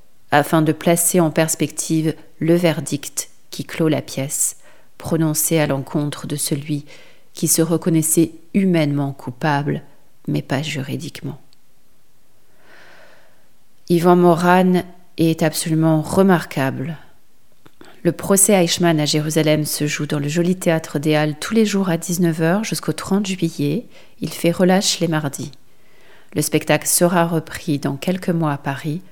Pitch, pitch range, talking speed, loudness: 160 Hz, 150-175 Hz, 130 wpm, -18 LUFS